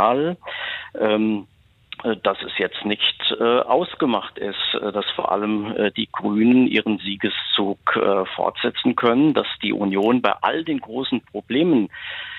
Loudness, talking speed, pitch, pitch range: -21 LUFS, 110 wpm, 110 Hz, 105-125 Hz